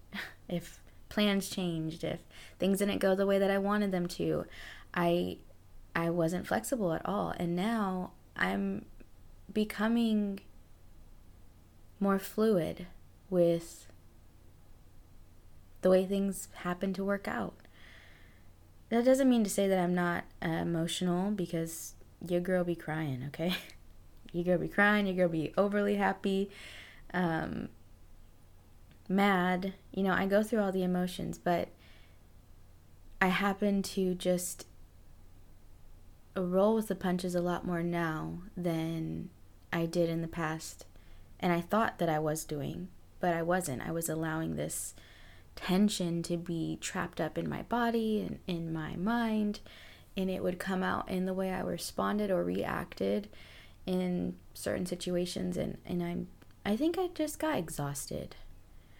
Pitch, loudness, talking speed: 175 Hz, -33 LUFS, 140 wpm